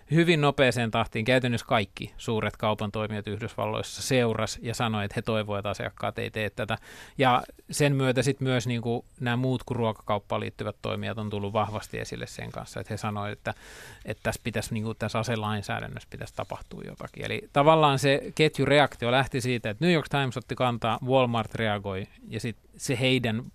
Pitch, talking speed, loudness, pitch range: 115 Hz, 180 wpm, -27 LUFS, 105-130 Hz